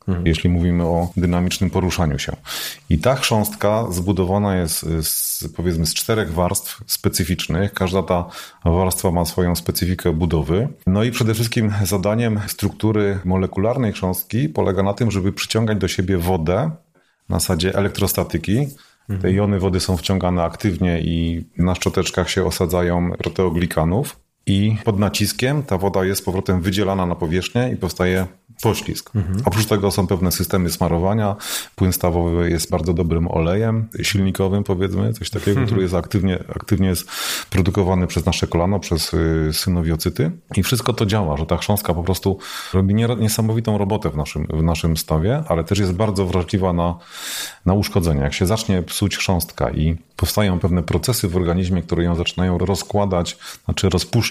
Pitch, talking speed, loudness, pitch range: 95 Hz, 150 wpm, -20 LUFS, 85-105 Hz